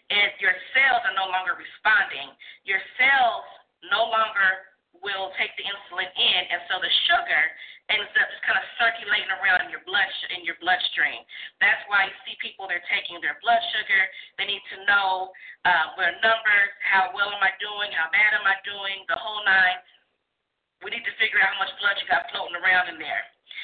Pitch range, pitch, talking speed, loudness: 190-220 Hz, 200 Hz, 195 wpm, -22 LUFS